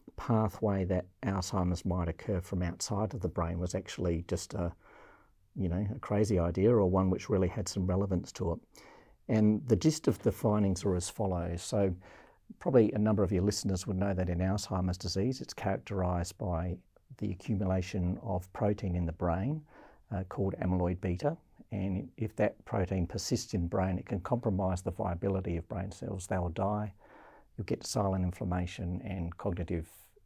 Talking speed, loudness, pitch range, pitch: 175 wpm, -33 LUFS, 90-105 Hz, 95 Hz